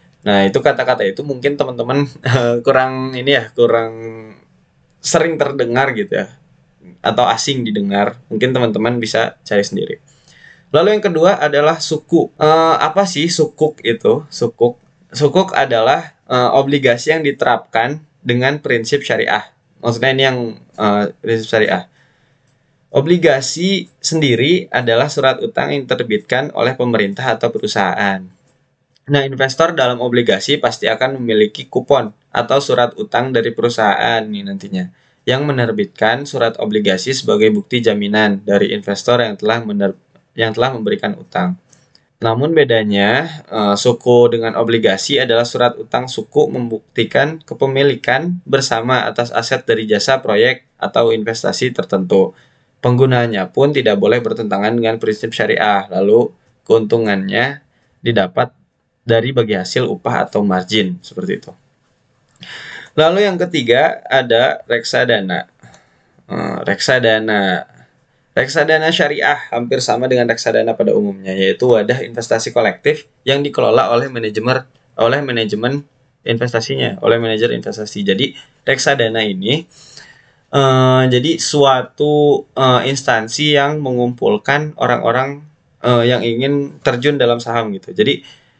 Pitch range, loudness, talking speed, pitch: 115-145 Hz, -15 LUFS, 120 wpm, 125 Hz